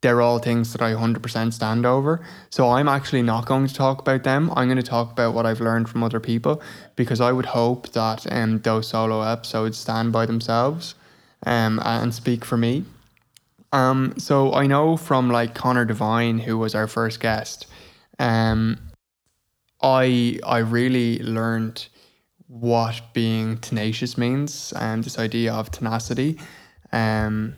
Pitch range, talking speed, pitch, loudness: 115-130 Hz, 160 wpm, 115 Hz, -22 LUFS